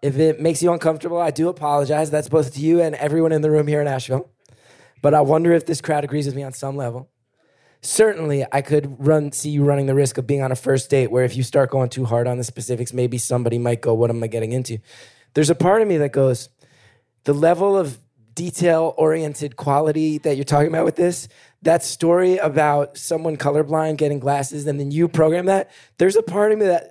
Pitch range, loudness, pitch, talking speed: 130-160 Hz, -19 LUFS, 145 Hz, 230 wpm